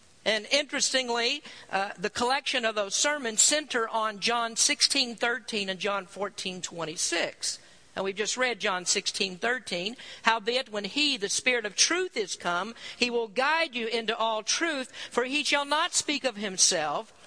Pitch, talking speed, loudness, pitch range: 235 Hz, 155 wpm, -27 LUFS, 205-265 Hz